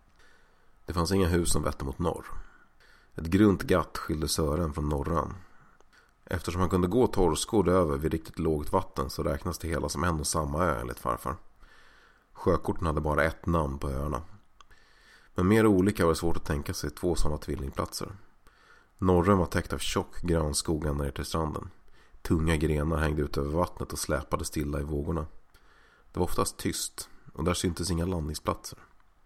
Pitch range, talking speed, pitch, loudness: 75-90 Hz, 175 wpm, 80 Hz, -29 LUFS